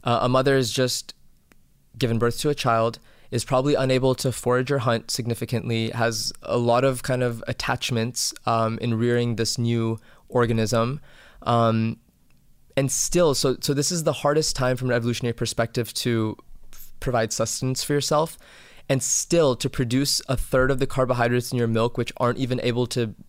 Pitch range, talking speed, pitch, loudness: 115-130 Hz, 175 wpm, 120 Hz, -23 LUFS